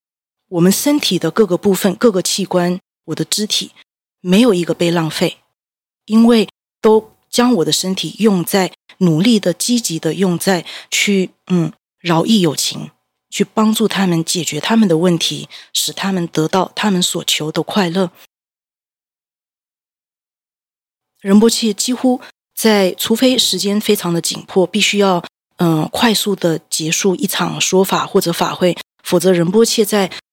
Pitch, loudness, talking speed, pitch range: 185 Hz, -15 LUFS, 220 characters per minute, 170-215 Hz